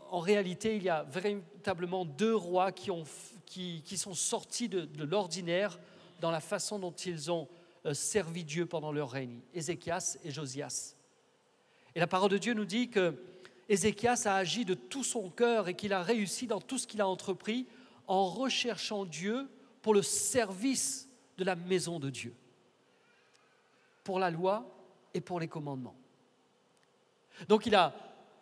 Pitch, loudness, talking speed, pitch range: 190 Hz, -34 LUFS, 165 wpm, 170-215 Hz